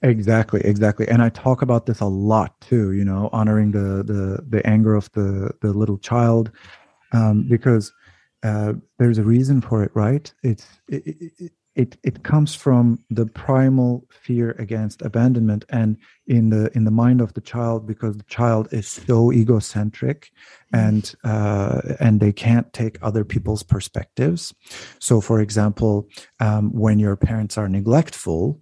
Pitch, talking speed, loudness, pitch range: 110 Hz, 160 wpm, -20 LUFS, 105-120 Hz